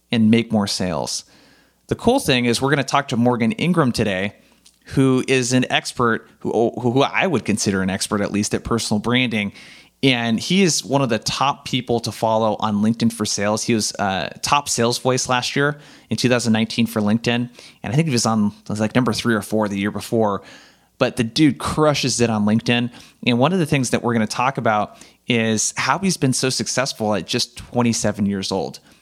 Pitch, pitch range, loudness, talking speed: 115 Hz, 110-130 Hz, -19 LUFS, 215 wpm